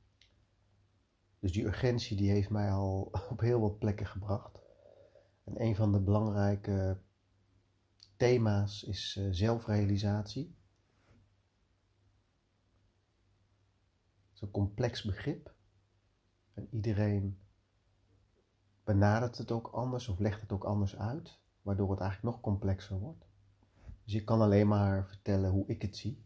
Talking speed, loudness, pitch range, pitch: 120 wpm, -34 LUFS, 95-105 Hz, 100 Hz